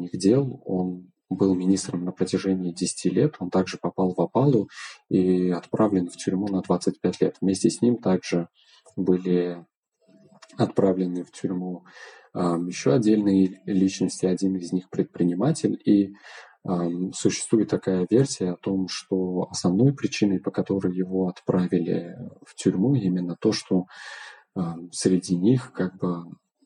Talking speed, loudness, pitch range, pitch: 135 wpm, -24 LUFS, 90-95 Hz, 95 Hz